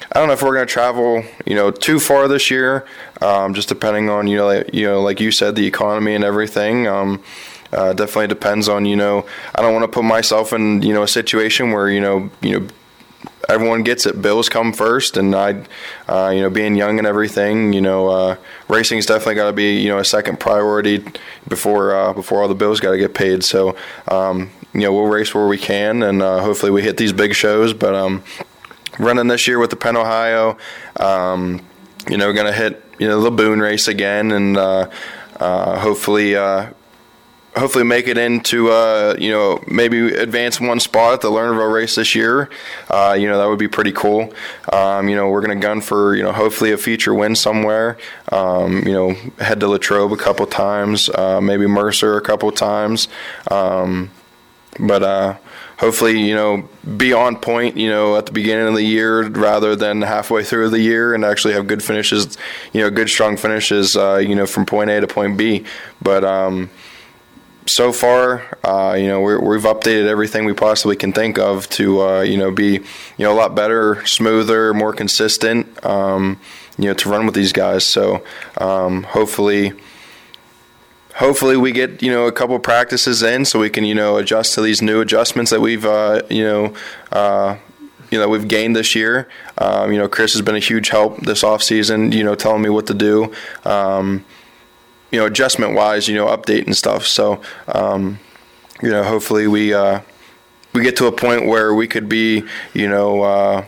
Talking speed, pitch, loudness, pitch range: 195 wpm, 105 Hz, -15 LUFS, 100-110 Hz